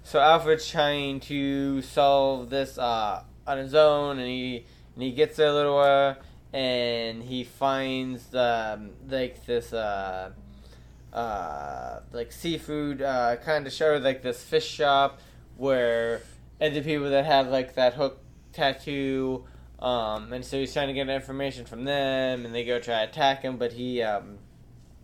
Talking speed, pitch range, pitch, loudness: 165 wpm, 120-140 Hz, 130 Hz, -26 LUFS